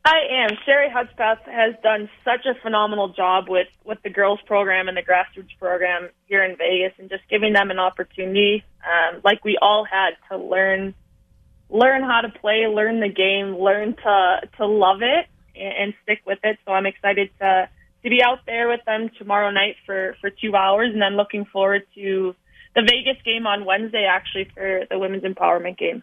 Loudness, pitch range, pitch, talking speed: -20 LUFS, 190-220 Hz, 200 Hz, 195 wpm